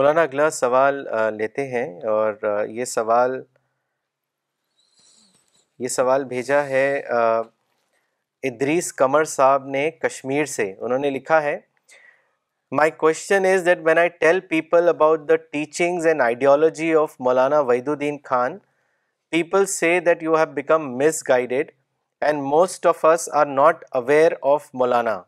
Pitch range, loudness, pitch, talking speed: 130-160 Hz, -20 LUFS, 145 Hz, 135 wpm